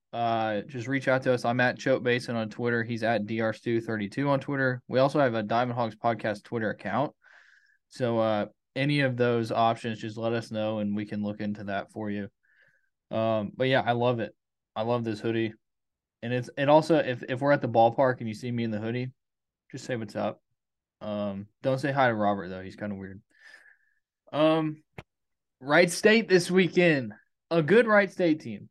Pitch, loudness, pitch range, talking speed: 120 Hz, -27 LUFS, 110-135 Hz, 205 wpm